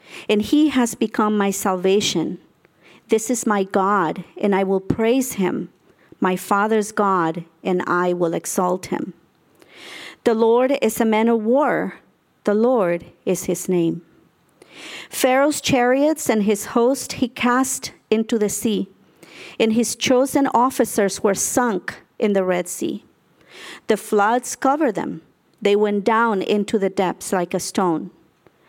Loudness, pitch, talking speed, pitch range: -20 LUFS, 215 Hz, 140 wpm, 190-245 Hz